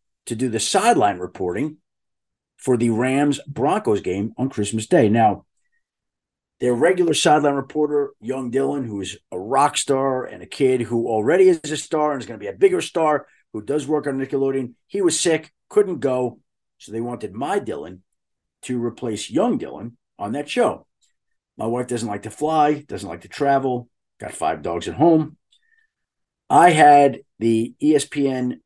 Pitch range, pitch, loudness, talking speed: 115-150 Hz, 135 Hz, -20 LUFS, 170 wpm